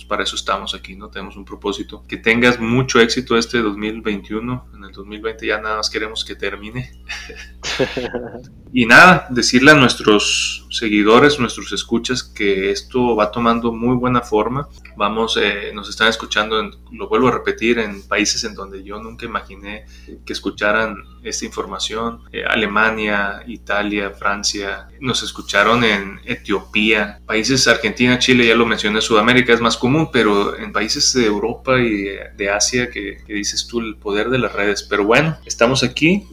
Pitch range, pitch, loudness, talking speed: 100-120 Hz, 110 Hz, -16 LUFS, 165 wpm